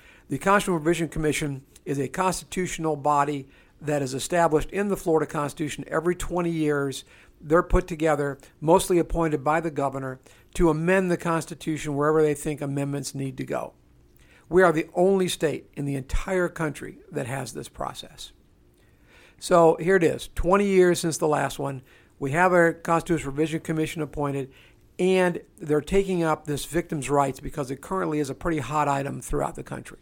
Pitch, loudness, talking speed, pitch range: 155 Hz, -25 LUFS, 170 wpm, 140-170 Hz